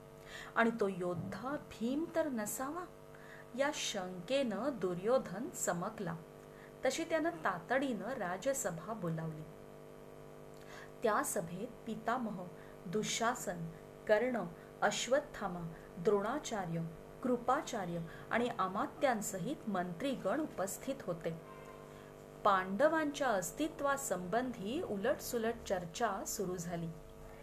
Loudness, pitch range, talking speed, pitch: -37 LUFS, 190-265 Hz, 75 wpm, 220 Hz